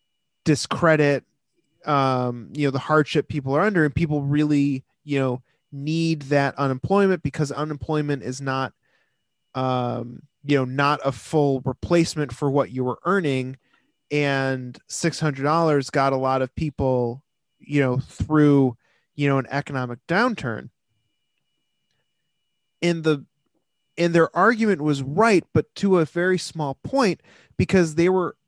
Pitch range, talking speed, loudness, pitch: 135-160 Hz, 135 wpm, -22 LUFS, 145 Hz